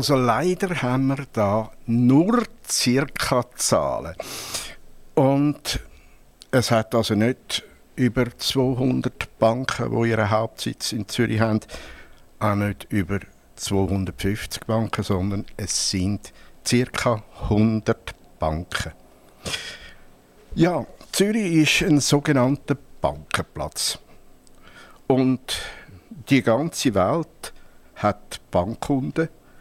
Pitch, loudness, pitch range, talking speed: 115 Hz, -23 LUFS, 110-135 Hz, 90 wpm